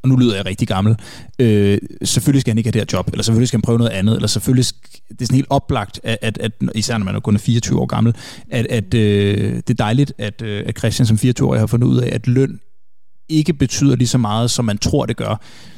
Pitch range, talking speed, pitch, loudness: 105-125 Hz, 260 wpm, 115 Hz, -17 LUFS